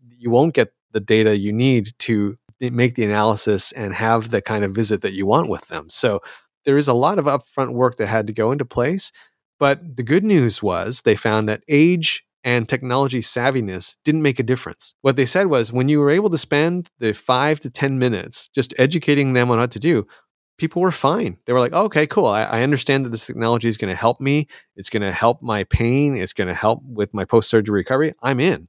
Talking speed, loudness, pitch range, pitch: 230 wpm, -19 LUFS, 110-140 Hz, 125 Hz